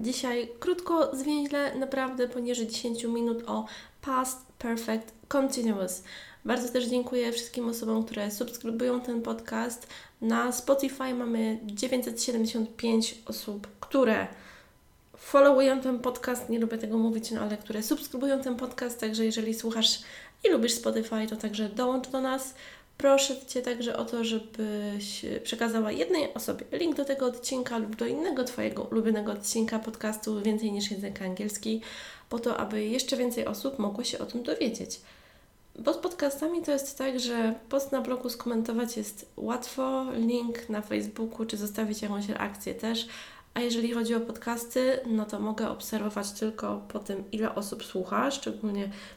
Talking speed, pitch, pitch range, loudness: 150 wpm, 235 Hz, 220-255 Hz, -30 LUFS